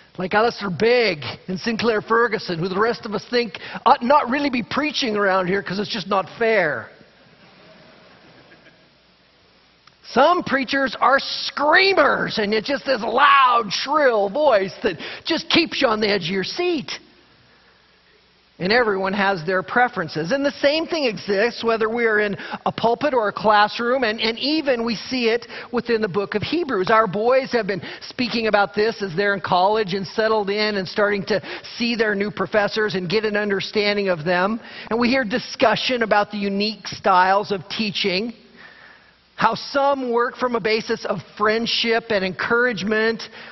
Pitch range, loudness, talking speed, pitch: 200-245 Hz, -20 LUFS, 170 wpm, 220 Hz